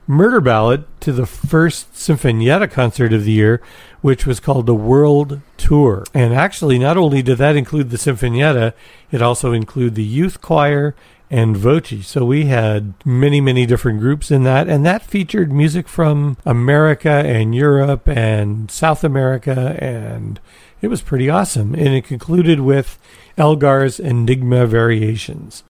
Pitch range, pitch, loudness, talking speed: 120-150 Hz, 135 Hz, -15 LUFS, 150 wpm